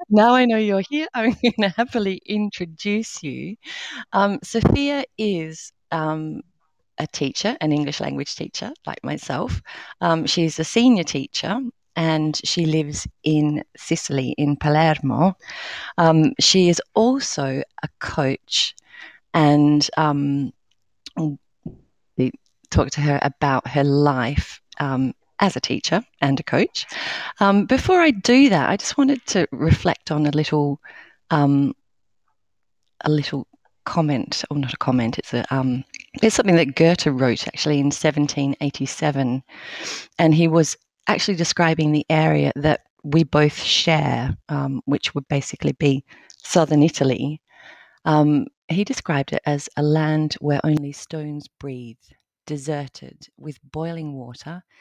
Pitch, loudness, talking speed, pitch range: 155 Hz, -20 LUFS, 135 wpm, 140-180 Hz